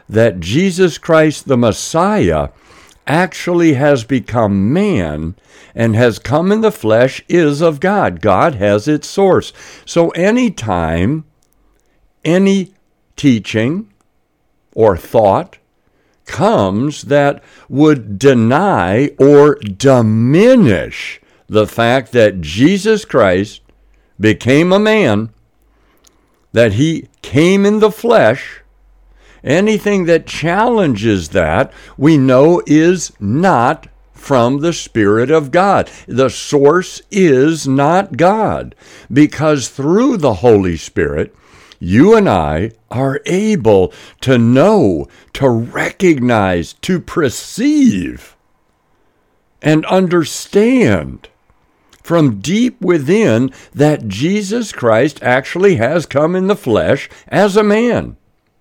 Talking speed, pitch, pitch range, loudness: 100 wpm, 145 Hz, 115-185 Hz, -12 LUFS